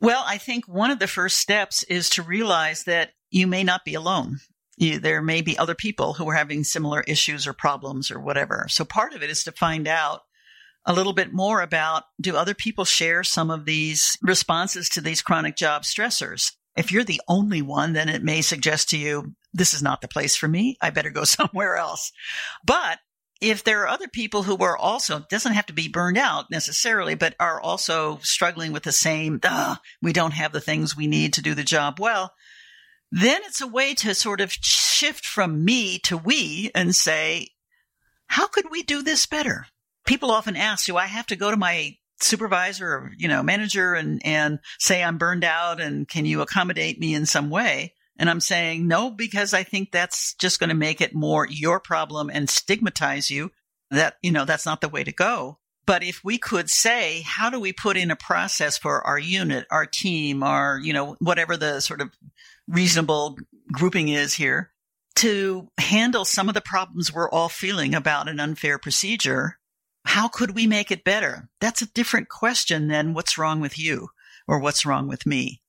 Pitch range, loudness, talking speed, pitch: 155-205 Hz, -22 LUFS, 200 wpm, 175 Hz